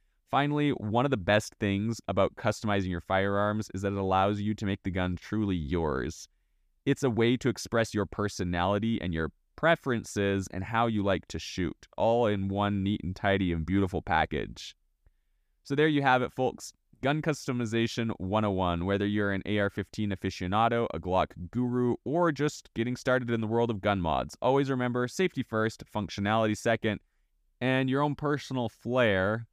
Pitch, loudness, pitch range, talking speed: 105 Hz, -29 LUFS, 95-120 Hz, 175 wpm